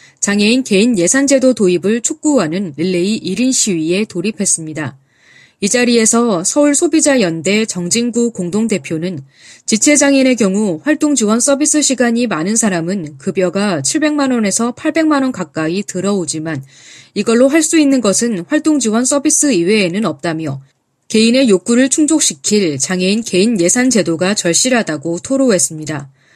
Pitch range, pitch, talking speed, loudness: 175-260 Hz, 210 Hz, 325 characters per minute, -13 LUFS